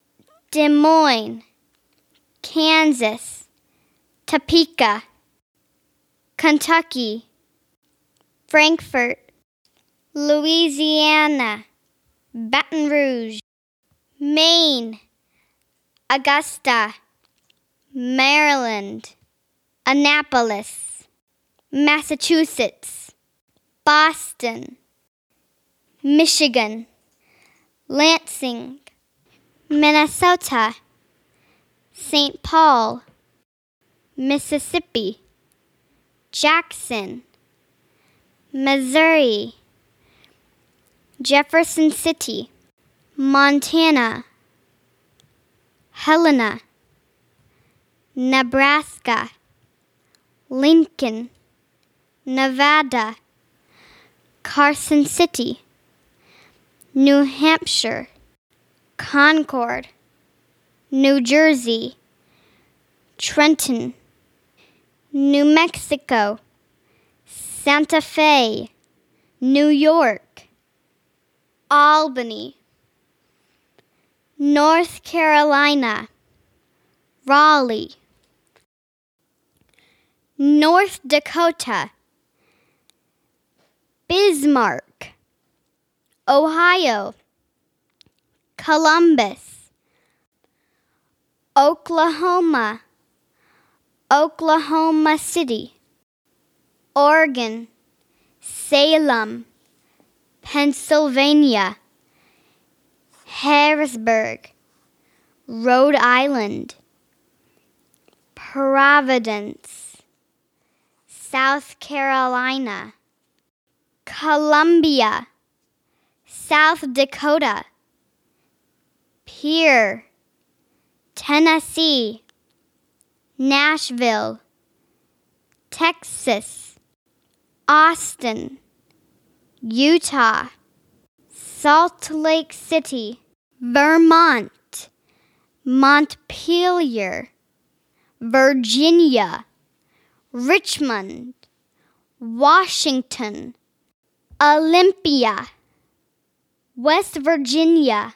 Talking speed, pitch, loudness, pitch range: 35 wpm, 290 Hz, -17 LUFS, 255-315 Hz